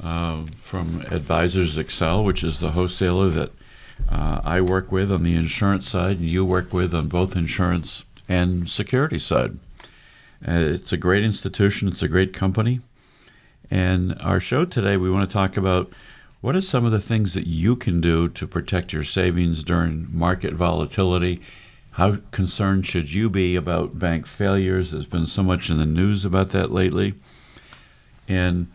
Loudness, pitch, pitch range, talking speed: -22 LUFS, 90 Hz, 85-95 Hz, 170 wpm